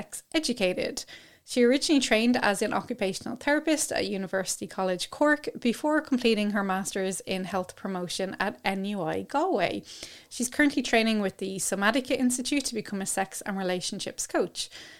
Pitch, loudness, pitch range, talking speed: 210 Hz, -27 LUFS, 190-255 Hz, 150 wpm